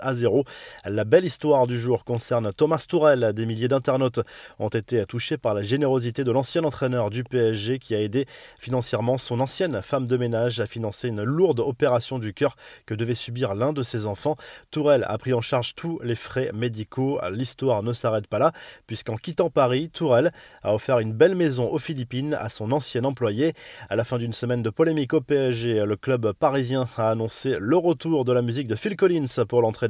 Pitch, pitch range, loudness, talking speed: 125 Hz, 115-140 Hz, -24 LUFS, 200 wpm